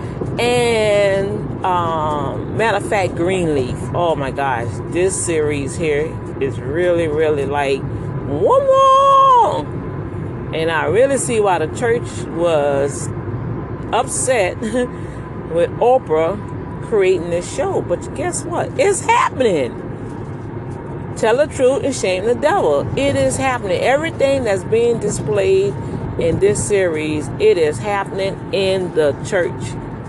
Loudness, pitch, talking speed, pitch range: -17 LUFS, 160 Hz, 120 wpm, 135-205 Hz